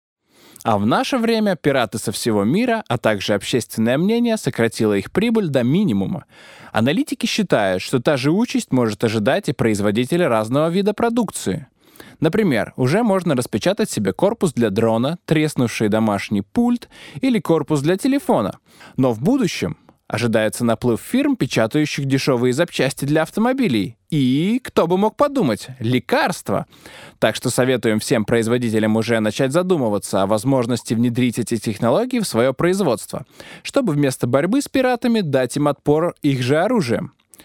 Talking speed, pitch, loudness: 145 wpm, 140 Hz, -19 LUFS